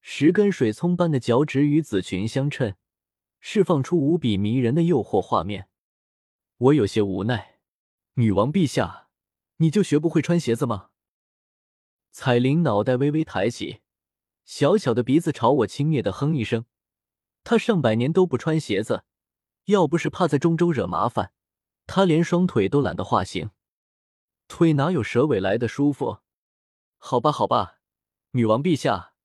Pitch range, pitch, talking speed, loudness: 110-170 Hz, 140 Hz, 225 characters per minute, -22 LUFS